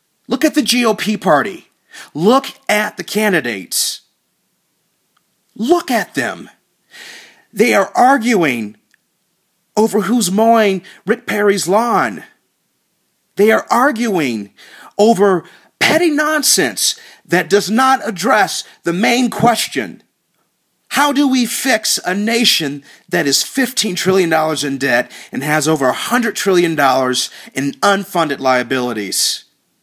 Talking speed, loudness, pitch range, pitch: 110 wpm, -14 LUFS, 160-240 Hz, 205 Hz